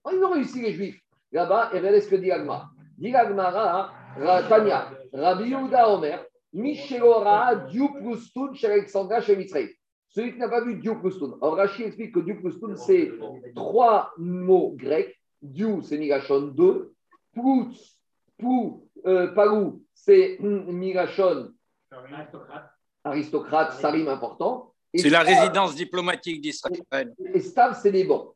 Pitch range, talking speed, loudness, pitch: 180-280 Hz, 135 wpm, -23 LUFS, 220 Hz